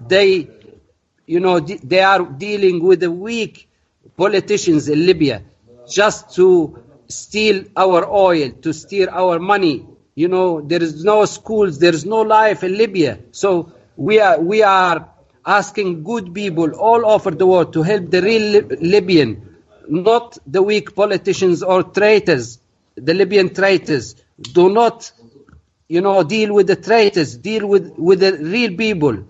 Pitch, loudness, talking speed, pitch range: 185 Hz, -15 LUFS, 150 wpm, 165-205 Hz